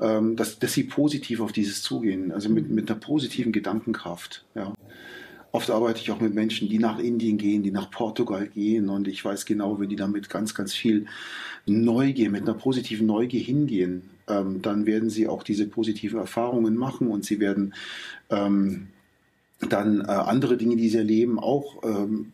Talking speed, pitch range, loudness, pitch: 175 wpm, 100-115 Hz, -25 LUFS, 110 Hz